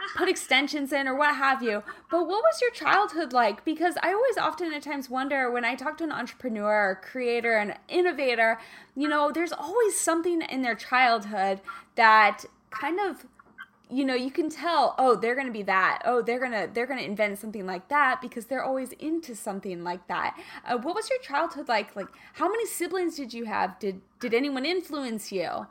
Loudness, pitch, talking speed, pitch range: -26 LUFS, 260 Hz, 205 wpm, 225-325 Hz